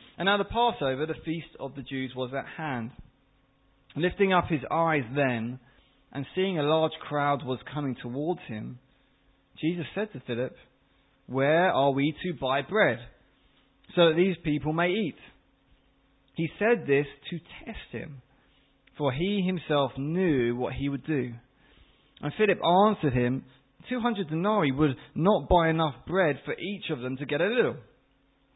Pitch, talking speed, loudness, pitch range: 145 Hz, 160 wpm, -28 LUFS, 135-175 Hz